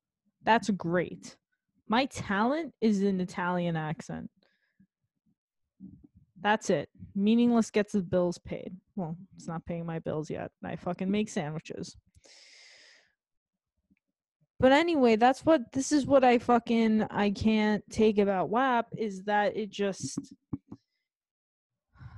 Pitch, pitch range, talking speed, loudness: 205 Hz, 180-230 Hz, 120 wpm, -28 LUFS